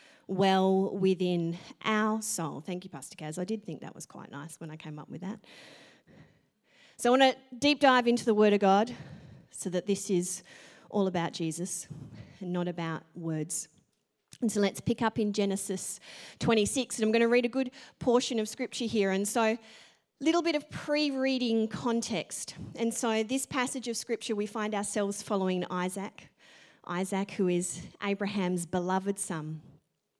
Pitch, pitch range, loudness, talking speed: 200 Hz, 180-230 Hz, -30 LUFS, 175 wpm